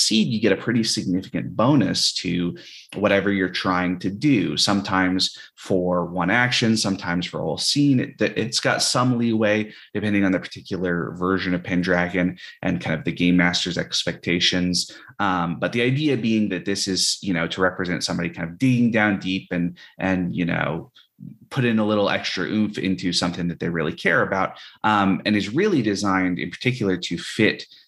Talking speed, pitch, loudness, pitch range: 185 wpm, 95 Hz, -22 LUFS, 90-105 Hz